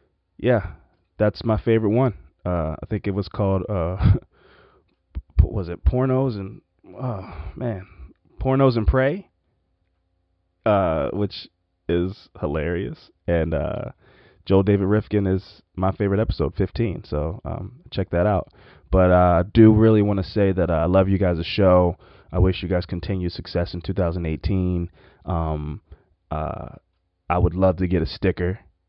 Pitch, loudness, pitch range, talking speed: 95 Hz, -22 LUFS, 85-105 Hz, 150 wpm